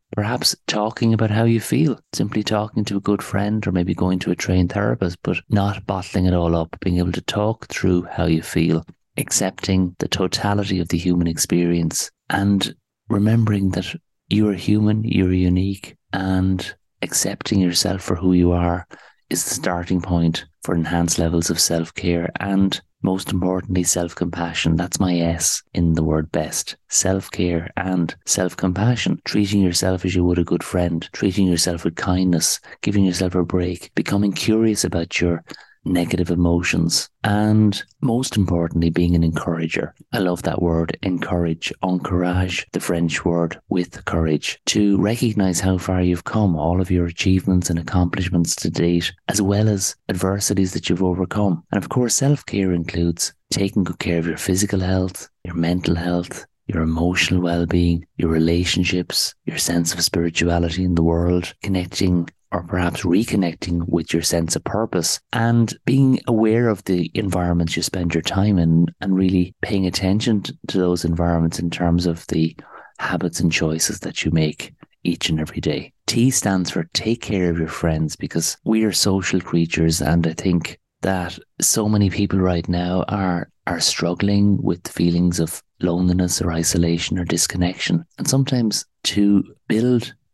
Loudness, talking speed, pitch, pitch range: -20 LUFS, 165 wpm, 90 Hz, 85-100 Hz